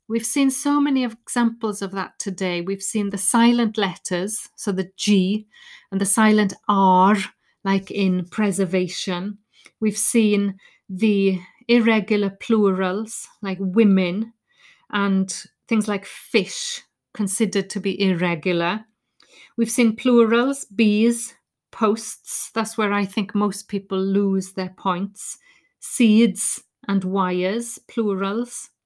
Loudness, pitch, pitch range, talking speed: -21 LUFS, 205 Hz, 195-230 Hz, 115 wpm